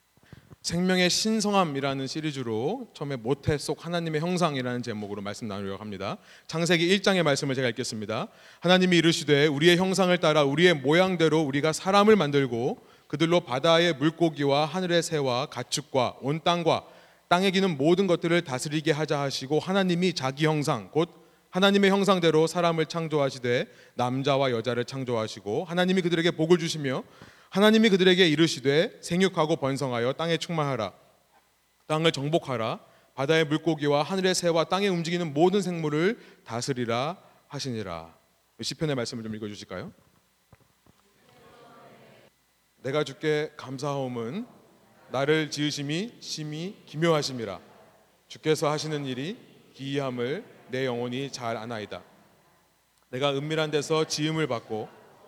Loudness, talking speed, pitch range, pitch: -26 LUFS, 335 characters per minute, 130-175 Hz, 155 Hz